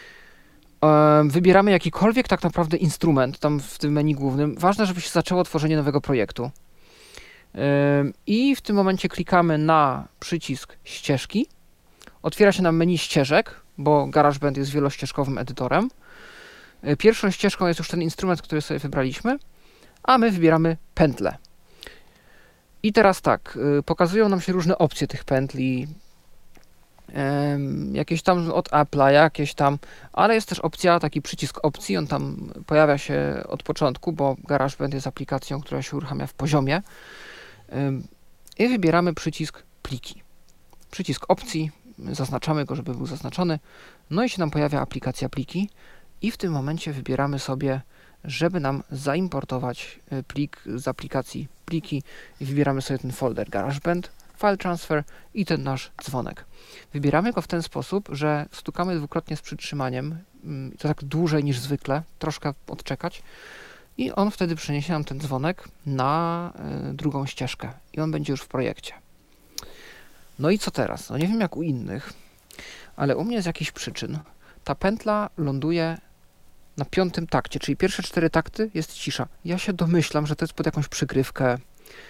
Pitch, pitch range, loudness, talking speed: 155 Hz, 140-175 Hz, -24 LUFS, 145 wpm